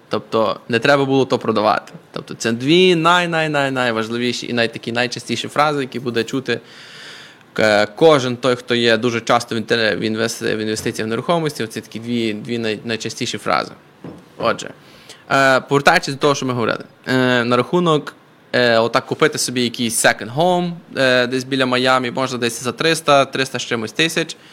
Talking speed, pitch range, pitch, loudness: 150 wpm, 115-140 Hz, 125 Hz, -17 LUFS